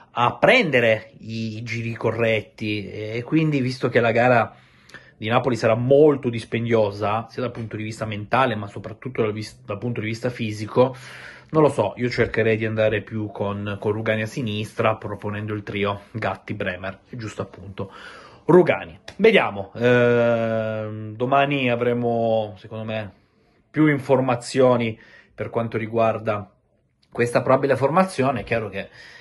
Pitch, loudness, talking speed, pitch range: 110 Hz, -22 LUFS, 140 wpm, 105-120 Hz